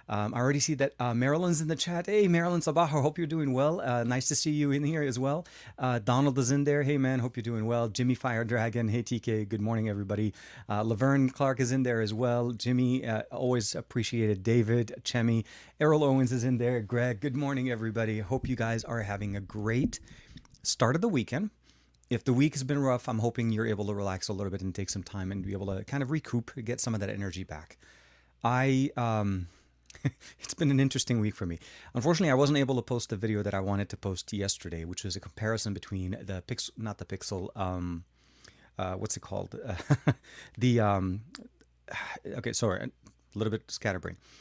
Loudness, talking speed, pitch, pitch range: -30 LUFS, 215 wpm, 120 Hz, 105-135 Hz